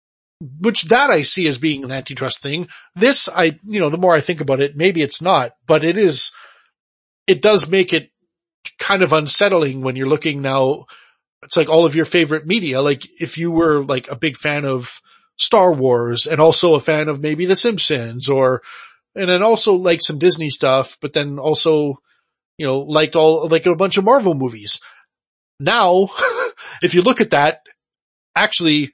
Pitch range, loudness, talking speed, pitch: 145-180 Hz, -15 LUFS, 185 wpm, 160 Hz